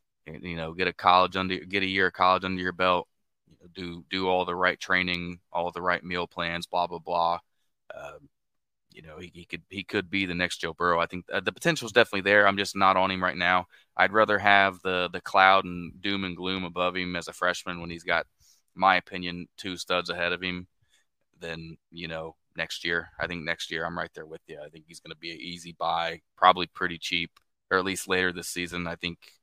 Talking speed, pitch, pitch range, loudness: 240 wpm, 90 Hz, 85-95 Hz, -26 LUFS